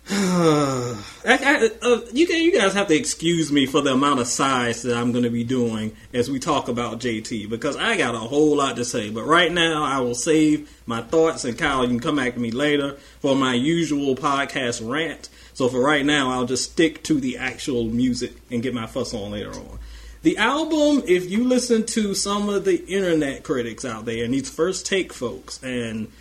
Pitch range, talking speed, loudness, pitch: 120-170 Hz, 215 wpm, -21 LUFS, 140 Hz